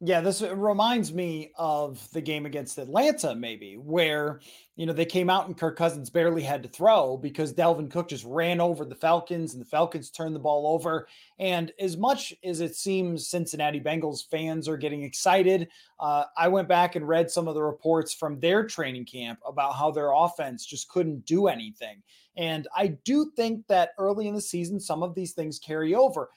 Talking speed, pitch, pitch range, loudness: 200 wpm, 165 Hz, 150-185 Hz, -27 LUFS